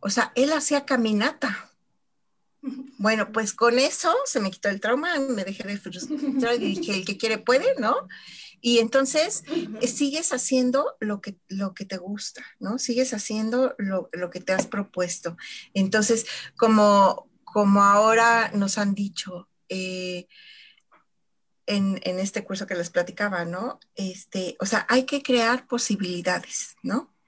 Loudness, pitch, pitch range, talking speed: -24 LUFS, 220 Hz, 195-255 Hz, 150 wpm